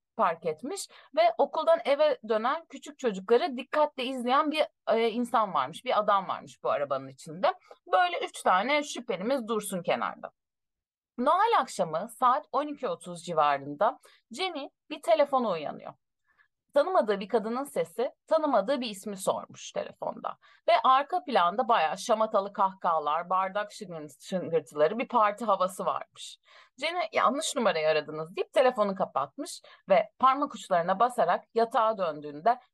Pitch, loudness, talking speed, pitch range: 245 Hz, -28 LUFS, 125 wpm, 190-295 Hz